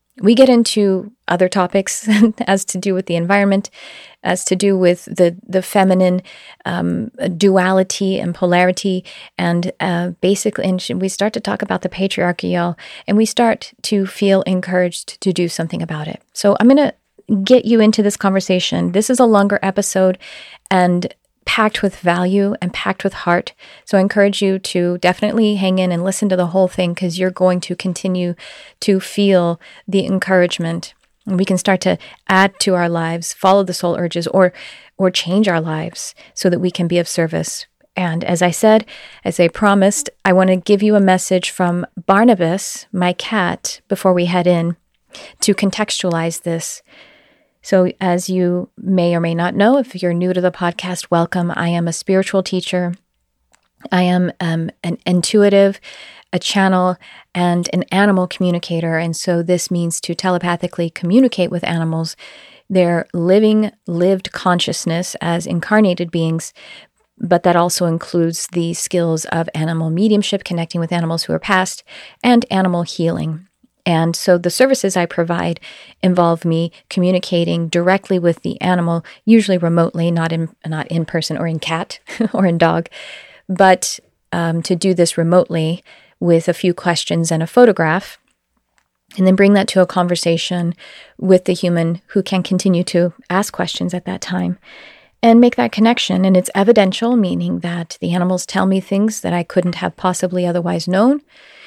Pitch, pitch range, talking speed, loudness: 185 Hz, 175-195 Hz, 165 wpm, -16 LUFS